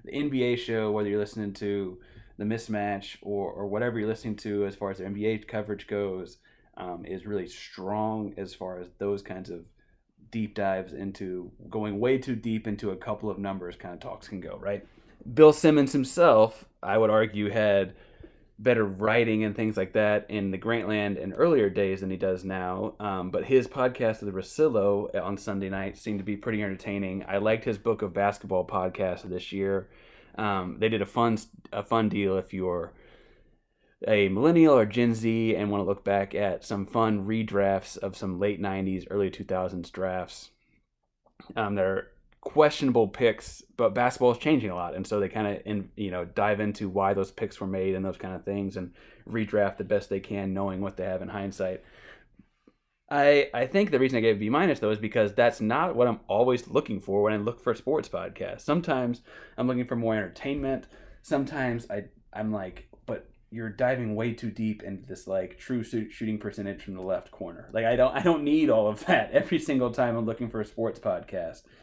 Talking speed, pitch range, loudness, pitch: 200 wpm, 95-115 Hz, -27 LUFS, 105 Hz